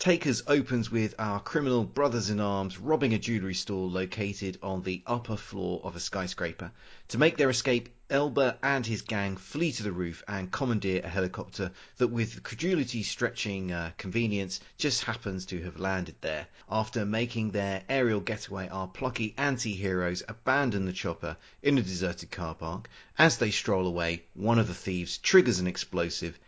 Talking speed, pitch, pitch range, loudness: 170 wpm, 105 Hz, 95-120 Hz, -30 LUFS